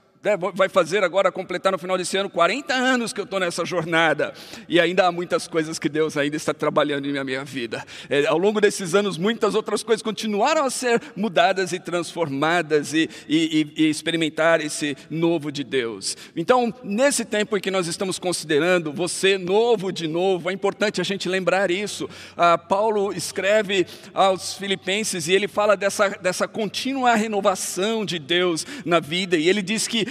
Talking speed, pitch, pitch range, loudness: 180 wpm, 190 Hz, 170-205 Hz, -22 LUFS